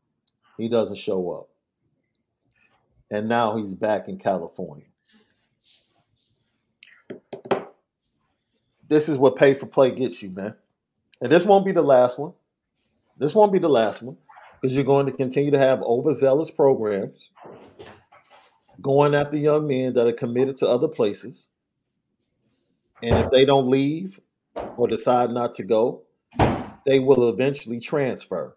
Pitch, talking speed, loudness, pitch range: 135 Hz, 135 wpm, -21 LUFS, 120-145 Hz